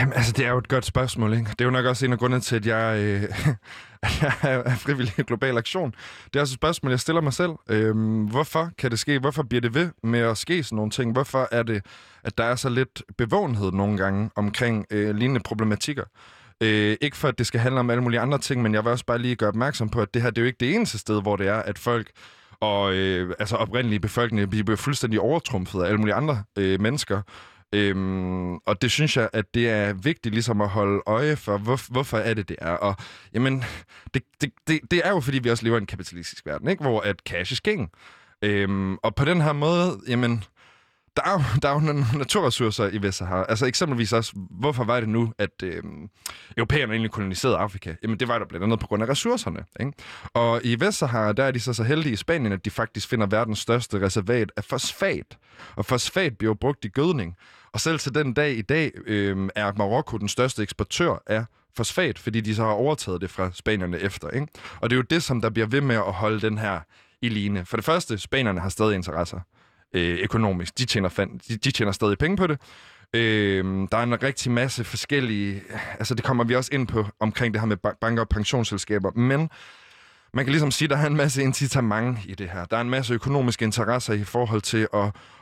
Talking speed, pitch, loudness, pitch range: 235 wpm, 115 Hz, -24 LUFS, 105-130 Hz